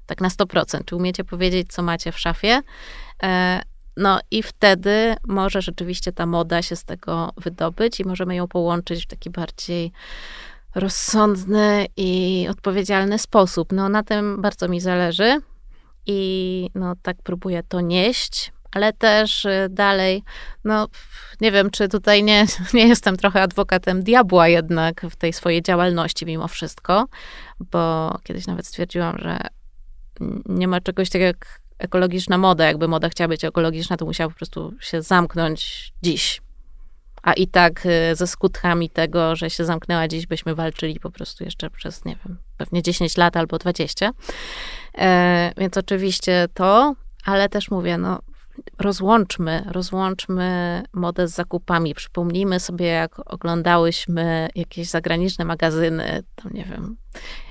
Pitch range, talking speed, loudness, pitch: 170-195 Hz, 140 wpm, -20 LUFS, 180 Hz